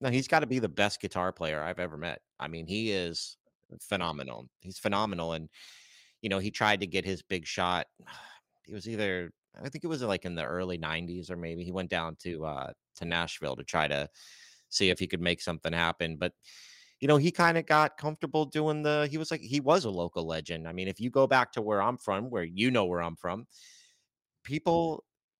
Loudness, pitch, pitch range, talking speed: -31 LUFS, 95 Hz, 85-130 Hz, 225 wpm